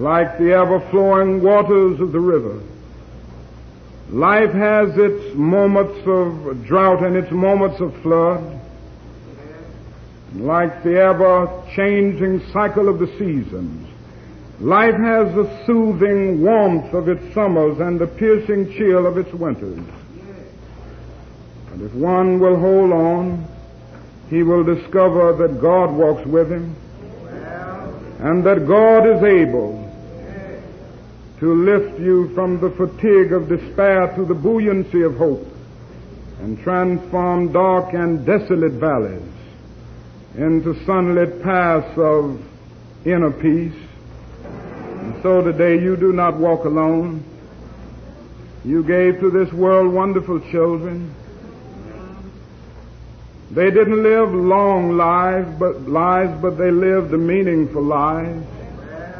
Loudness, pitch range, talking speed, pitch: -16 LUFS, 155-190 Hz, 115 wpm, 175 Hz